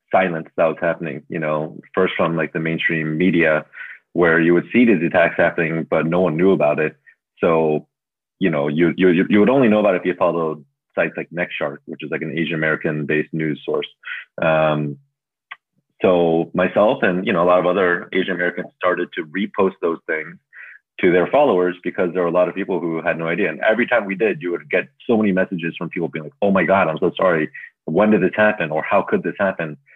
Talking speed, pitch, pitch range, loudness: 225 wpm, 85 Hz, 80-90 Hz, -19 LUFS